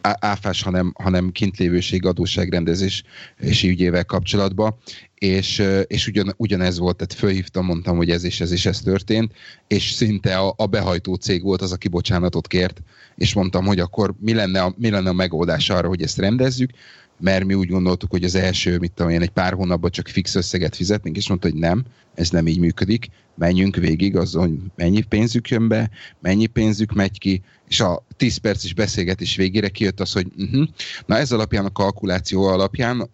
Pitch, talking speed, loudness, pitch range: 95 Hz, 180 wpm, -20 LUFS, 90-105 Hz